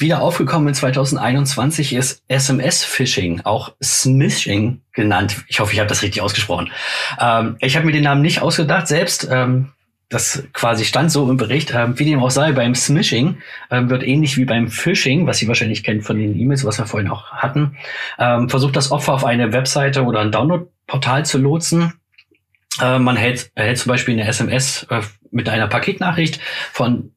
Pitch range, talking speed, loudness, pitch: 115-145 Hz, 185 wpm, -17 LUFS, 130 Hz